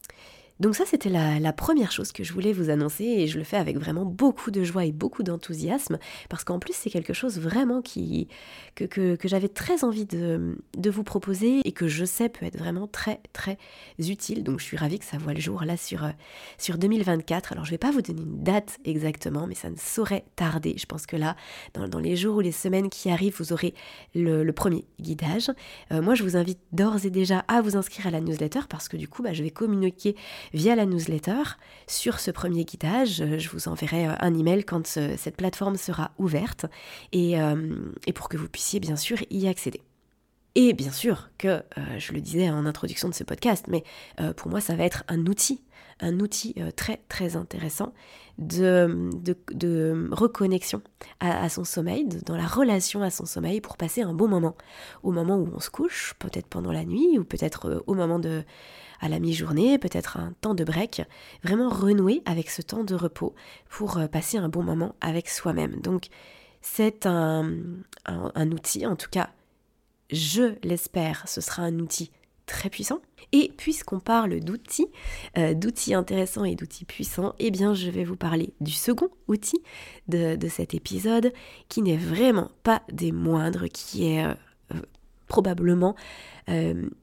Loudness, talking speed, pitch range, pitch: -27 LUFS, 195 wpm, 160-210 Hz, 180 Hz